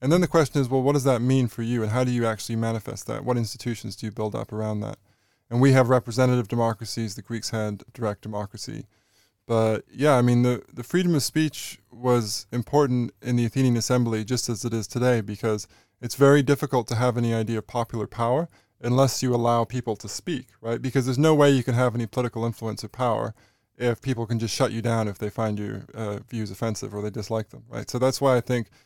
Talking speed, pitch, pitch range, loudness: 230 wpm, 120 Hz, 110-125 Hz, -25 LUFS